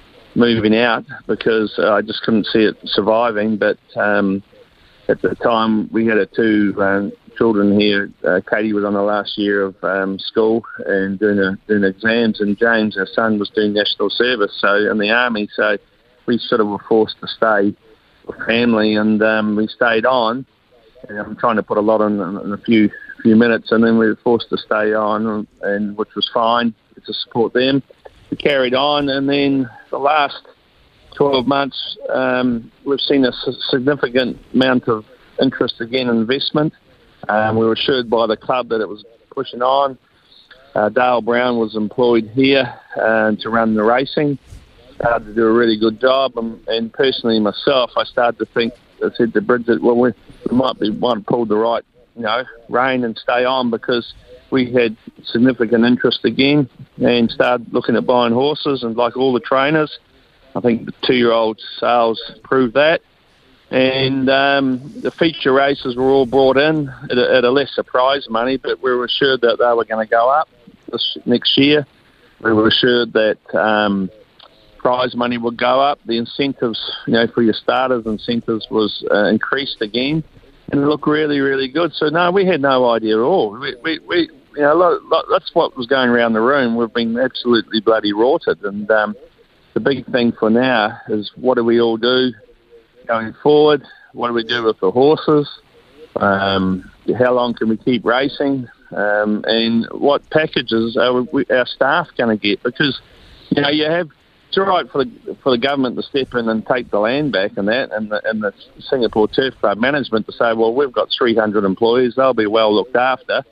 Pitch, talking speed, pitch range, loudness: 115 Hz, 190 wpm, 110-130 Hz, -16 LUFS